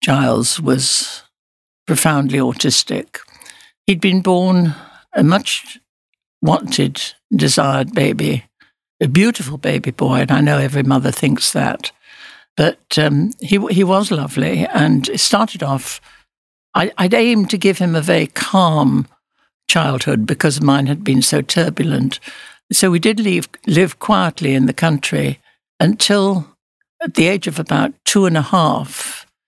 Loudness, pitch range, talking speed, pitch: -15 LUFS, 145-195 Hz, 140 wpm, 165 Hz